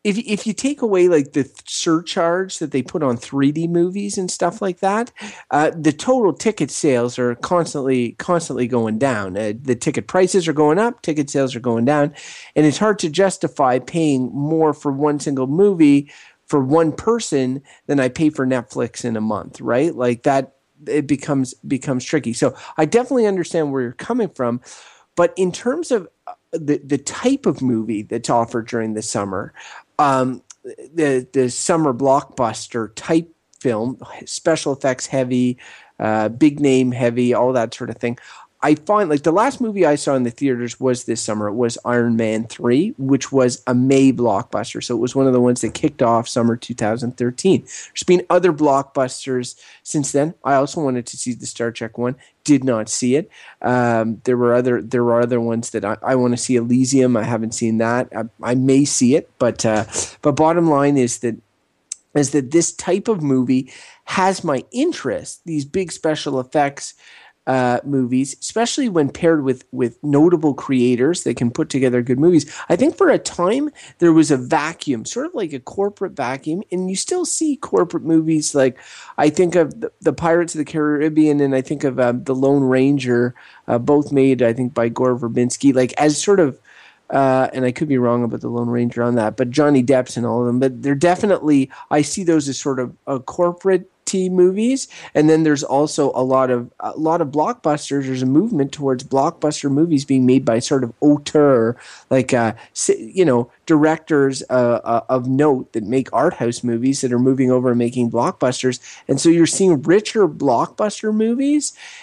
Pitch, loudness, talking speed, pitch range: 135 Hz, -18 LUFS, 195 wpm, 125-165 Hz